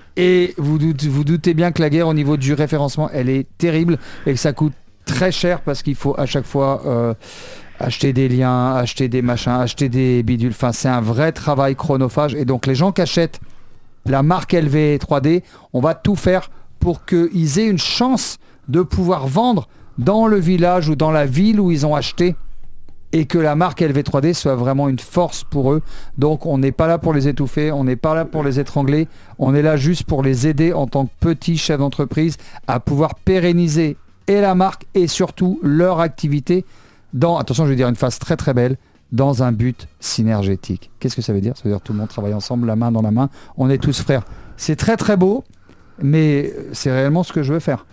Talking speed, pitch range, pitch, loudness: 215 wpm, 125-165 Hz, 145 Hz, -17 LUFS